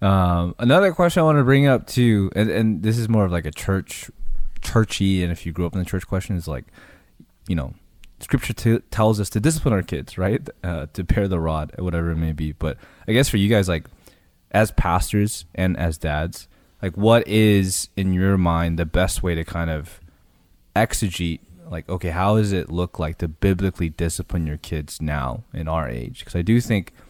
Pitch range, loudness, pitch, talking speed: 85-105 Hz, -21 LUFS, 90 Hz, 210 wpm